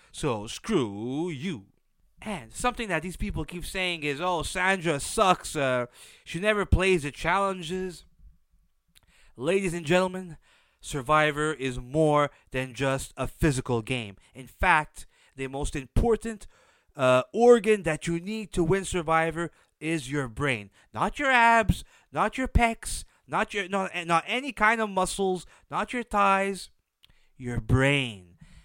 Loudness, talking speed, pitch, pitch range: -26 LUFS, 140 wpm, 165 Hz, 135-195 Hz